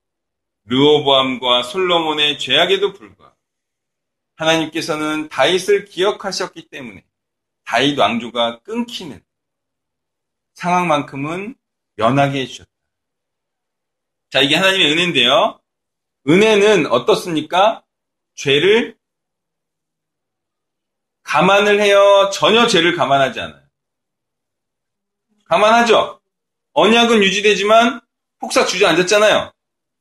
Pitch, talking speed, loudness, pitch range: 185 Hz, 225 characters per minute, -14 LUFS, 145-215 Hz